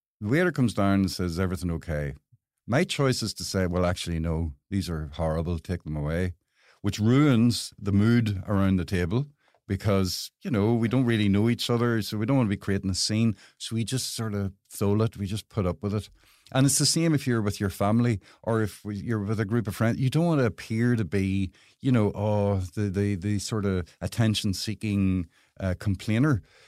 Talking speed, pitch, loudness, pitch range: 215 wpm, 105 Hz, -26 LUFS, 95-115 Hz